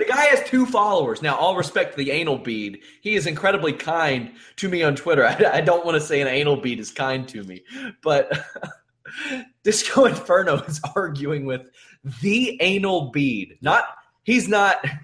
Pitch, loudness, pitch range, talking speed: 170 Hz, -21 LUFS, 140-210 Hz, 180 wpm